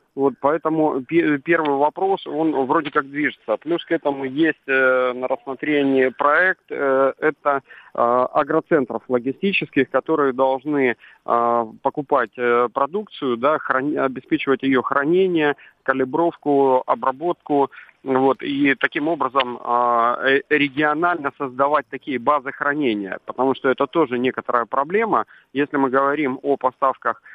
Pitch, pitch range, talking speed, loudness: 140 Hz, 130-150 Hz, 110 wpm, -20 LUFS